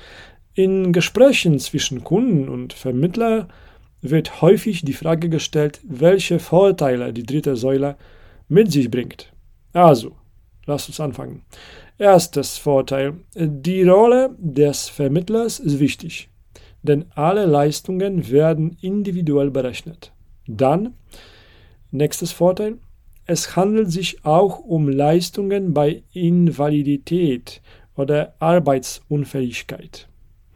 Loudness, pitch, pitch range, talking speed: -18 LUFS, 150 Hz, 135-180 Hz, 100 wpm